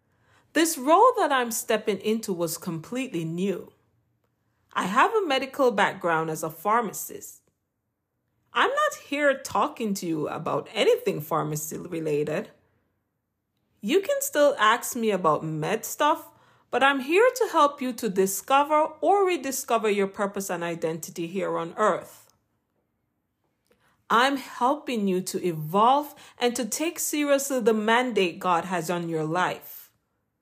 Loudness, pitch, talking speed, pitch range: -25 LUFS, 215 Hz, 135 wpm, 170-275 Hz